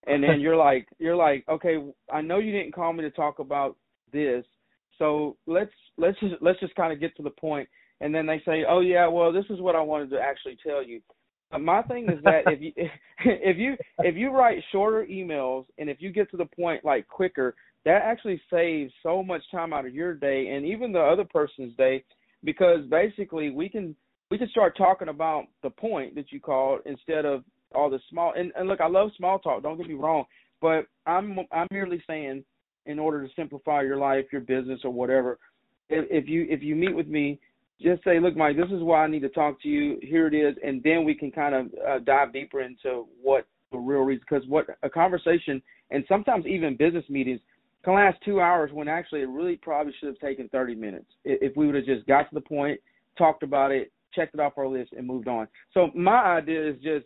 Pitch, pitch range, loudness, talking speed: 155 Hz, 140-175 Hz, -26 LUFS, 230 wpm